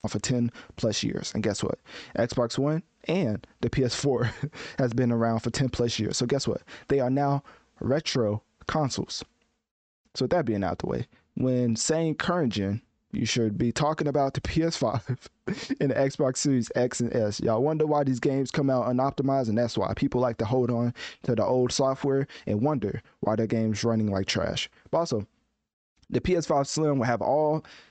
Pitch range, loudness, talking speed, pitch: 115-140 Hz, -27 LUFS, 190 wpm, 125 Hz